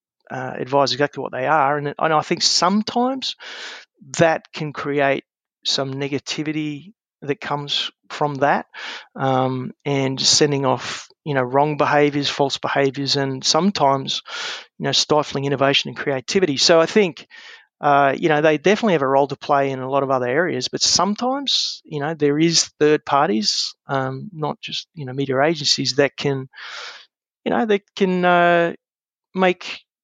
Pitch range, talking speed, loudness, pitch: 135-165 Hz, 160 wpm, -19 LUFS, 145 Hz